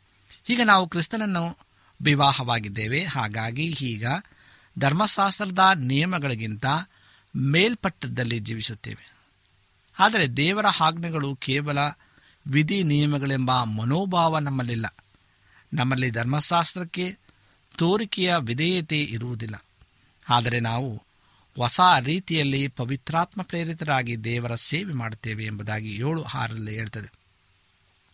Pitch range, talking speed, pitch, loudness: 110-165 Hz, 75 wpm, 135 Hz, -24 LUFS